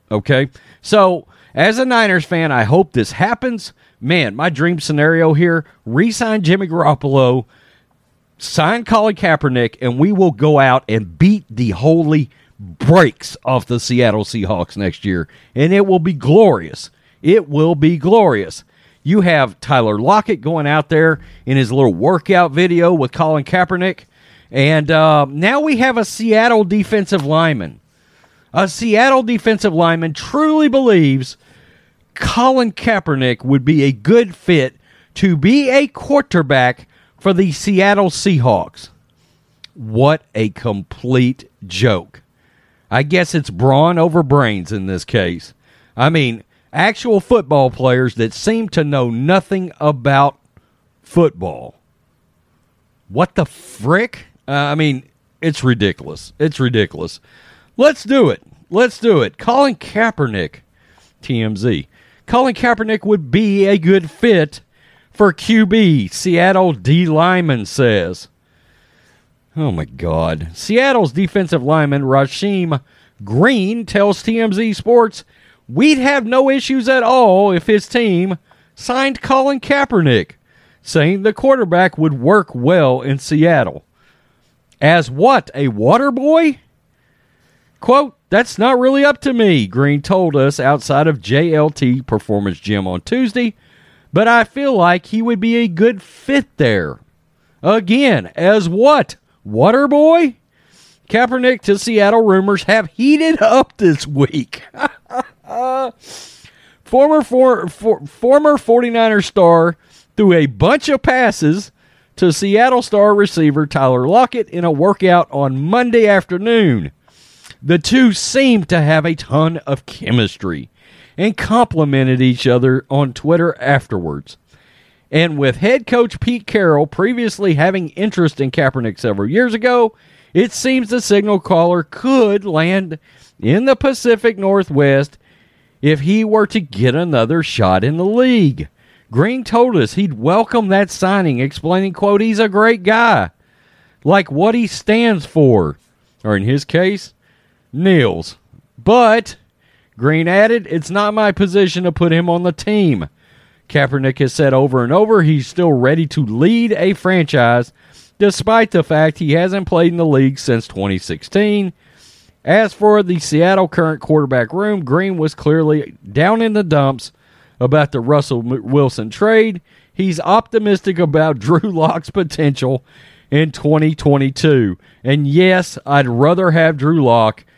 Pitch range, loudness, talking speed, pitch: 140-210 Hz, -14 LUFS, 135 wpm, 170 Hz